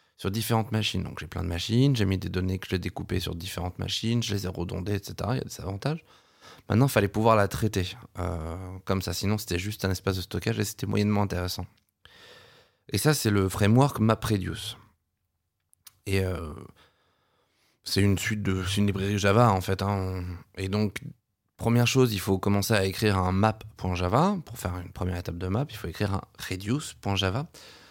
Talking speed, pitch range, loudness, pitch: 195 wpm, 95-110 Hz, -27 LUFS, 100 Hz